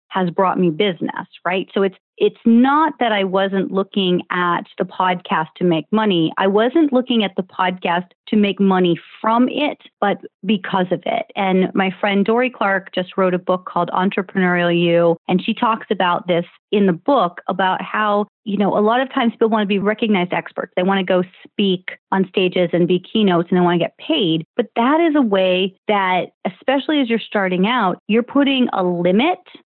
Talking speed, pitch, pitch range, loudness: 200 wpm, 195 Hz, 180-220 Hz, -18 LUFS